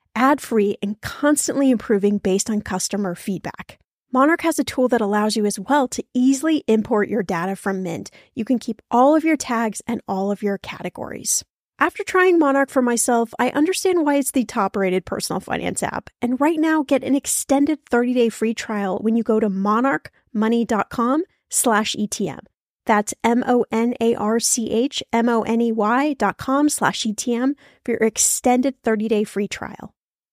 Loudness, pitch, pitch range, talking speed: -20 LUFS, 235 Hz, 210-270 Hz, 165 wpm